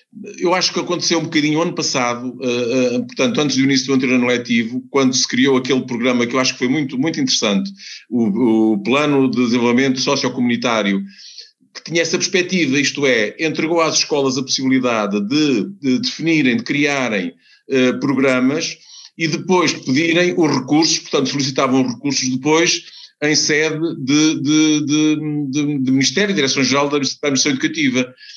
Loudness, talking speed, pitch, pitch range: -16 LUFS, 165 wpm, 145 Hz, 130-165 Hz